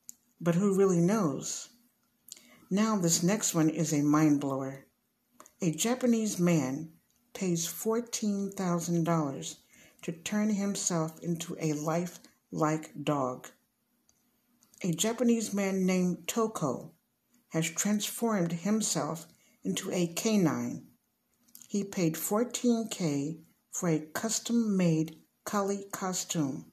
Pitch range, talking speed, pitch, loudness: 160-220 Hz, 105 wpm, 185 Hz, -30 LUFS